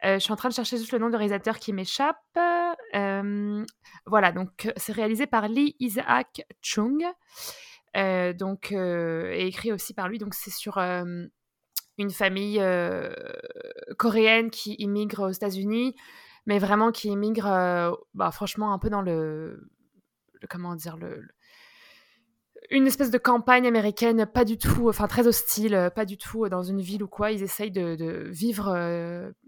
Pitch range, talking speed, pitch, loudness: 195-245 Hz, 170 wpm, 210 Hz, -26 LUFS